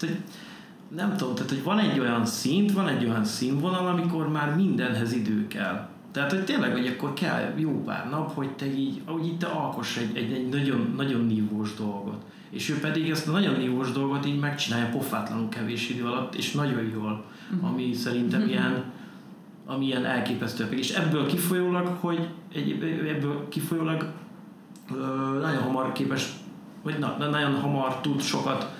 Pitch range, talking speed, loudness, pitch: 125-170 Hz, 160 wpm, -28 LUFS, 145 Hz